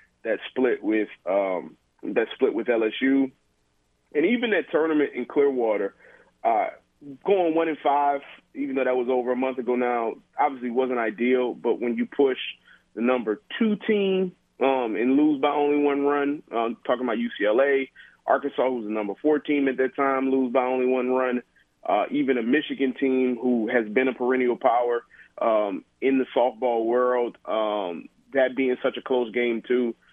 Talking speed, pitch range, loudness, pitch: 175 wpm, 120-145 Hz, -24 LUFS, 130 Hz